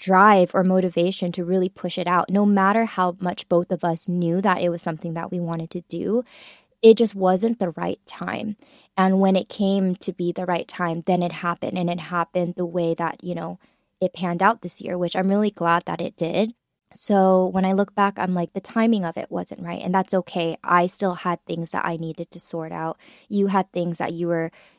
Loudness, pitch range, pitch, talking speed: -22 LUFS, 175-195 Hz, 180 Hz, 230 wpm